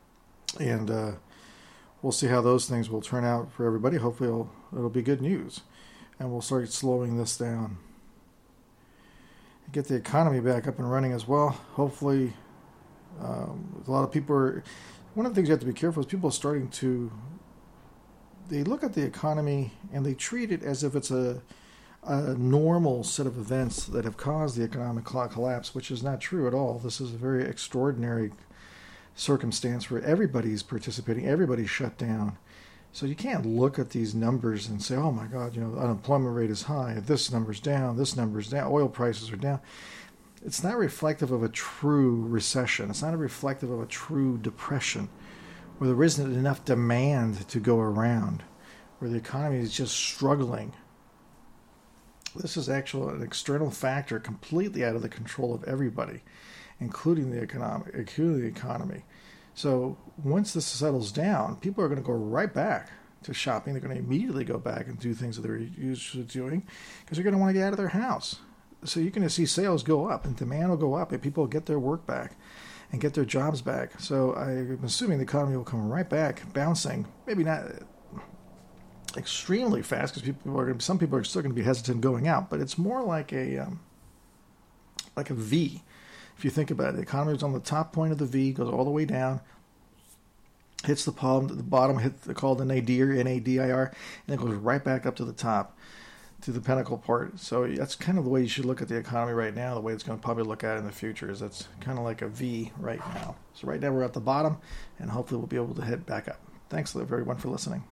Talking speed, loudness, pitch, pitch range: 210 wpm, -29 LUFS, 130 Hz, 120-145 Hz